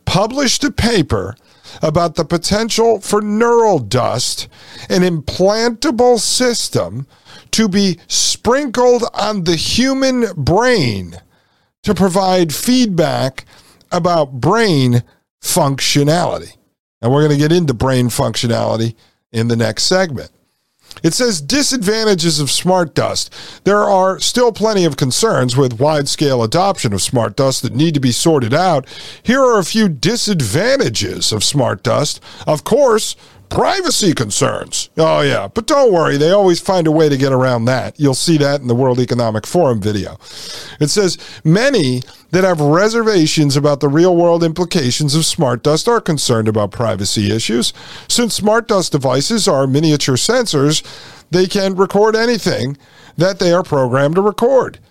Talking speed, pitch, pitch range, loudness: 145 wpm, 160 Hz, 130-200 Hz, -14 LUFS